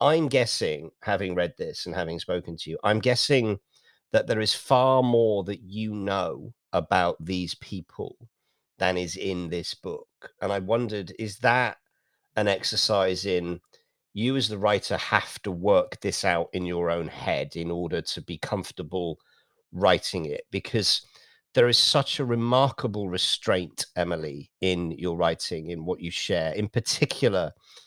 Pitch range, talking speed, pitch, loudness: 85-115 Hz, 155 wpm, 100 Hz, -26 LUFS